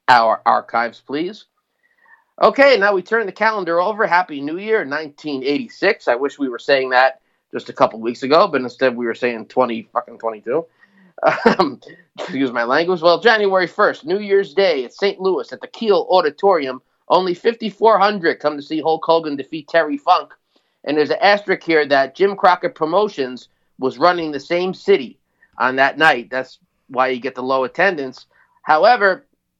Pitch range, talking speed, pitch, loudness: 135-195 Hz, 175 wpm, 165 Hz, -17 LUFS